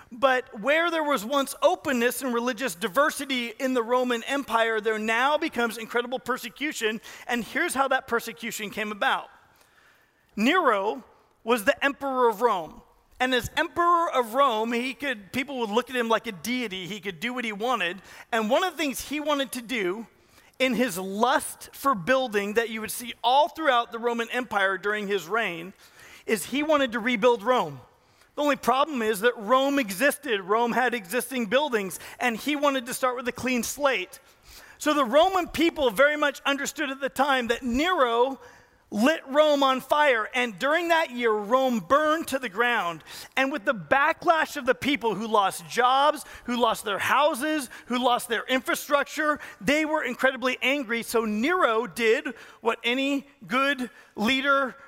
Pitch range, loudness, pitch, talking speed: 230-280 Hz, -25 LUFS, 255 Hz, 175 wpm